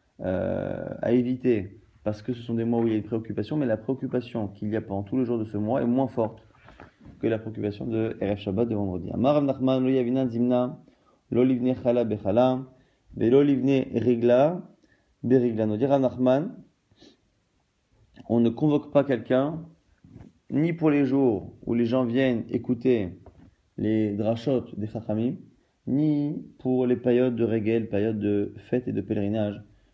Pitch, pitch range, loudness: 120 Hz, 110-130 Hz, -25 LUFS